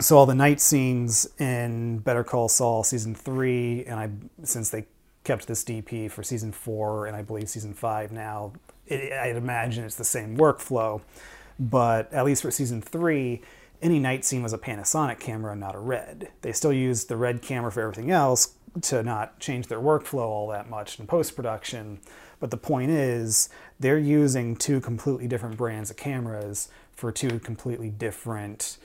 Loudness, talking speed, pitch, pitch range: -26 LUFS, 180 wpm, 120 Hz, 110-135 Hz